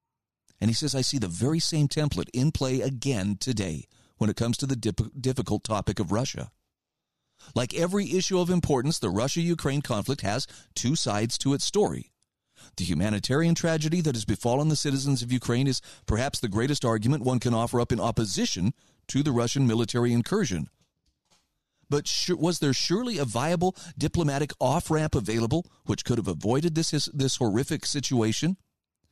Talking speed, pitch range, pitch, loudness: 170 wpm, 115-155 Hz, 130 Hz, -27 LUFS